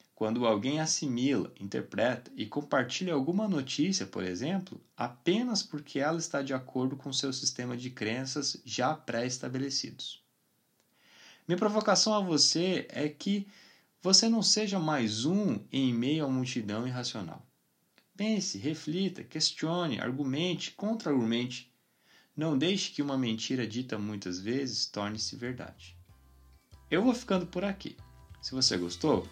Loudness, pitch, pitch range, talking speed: -31 LUFS, 140 Hz, 120-175 Hz, 130 wpm